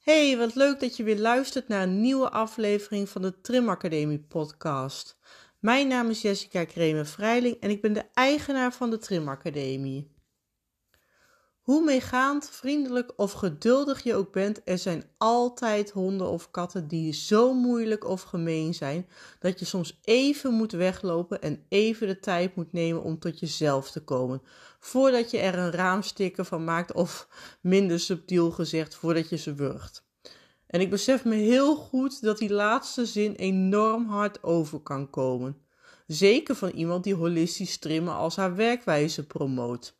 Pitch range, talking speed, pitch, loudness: 165-230 Hz, 160 wpm, 190 Hz, -27 LUFS